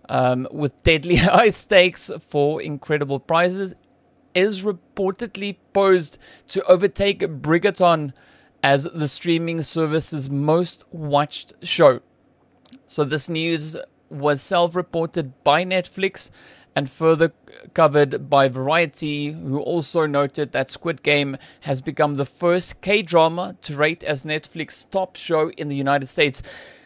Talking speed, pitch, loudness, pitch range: 125 wpm, 160 Hz, -20 LUFS, 145-180 Hz